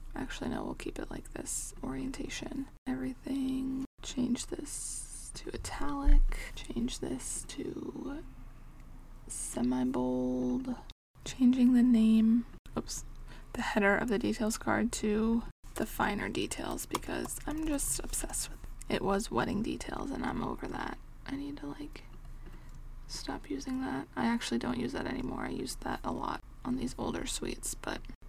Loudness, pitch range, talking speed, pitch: -34 LUFS, 200-285 Hz, 145 wpm, 250 Hz